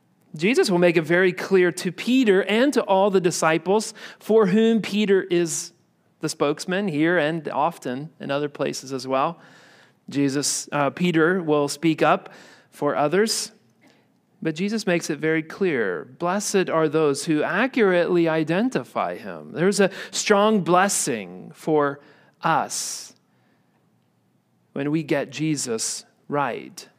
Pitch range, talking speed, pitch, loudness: 150-200 Hz, 135 wpm, 175 Hz, -22 LUFS